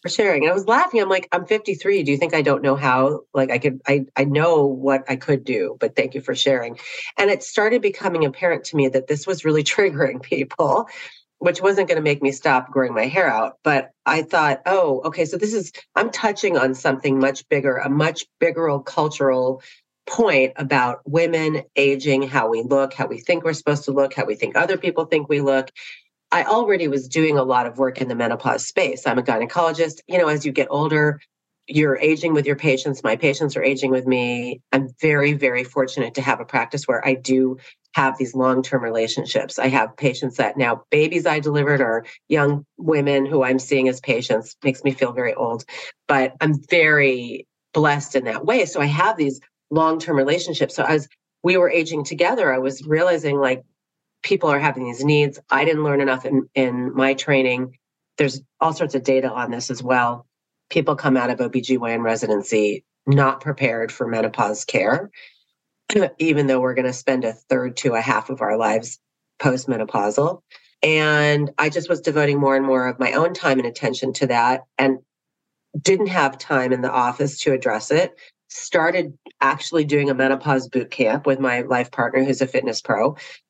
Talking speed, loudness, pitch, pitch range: 200 wpm, -20 LUFS, 140 Hz, 130-155 Hz